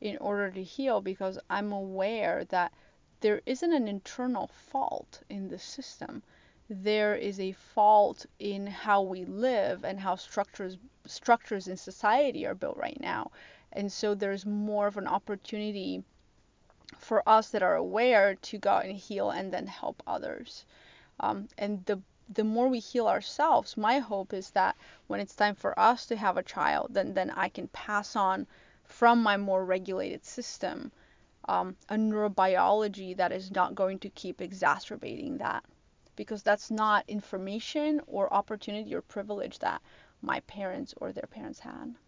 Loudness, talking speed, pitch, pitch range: -30 LUFS, 160 wpm, 205 Hz, 195-220 Hz